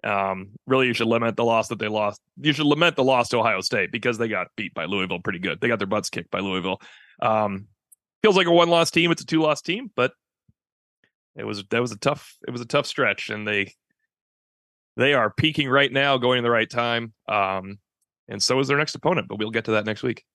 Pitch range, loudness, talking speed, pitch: 105-150 Hz, -22 LUFS, 245 wpm, 120 Hz